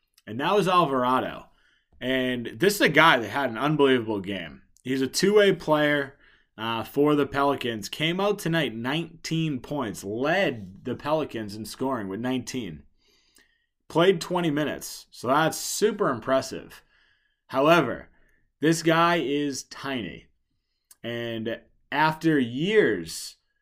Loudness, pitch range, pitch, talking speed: -25 LUFS, 120-160 Hz, 140 Hz, 125 wpm